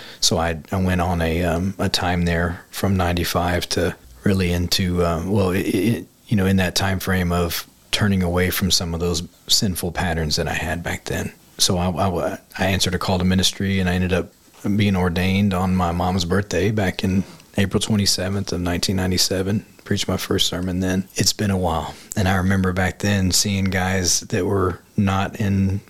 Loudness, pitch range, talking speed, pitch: -21 LUFS, 85-95 Hz, 195 wpm, 95 Hz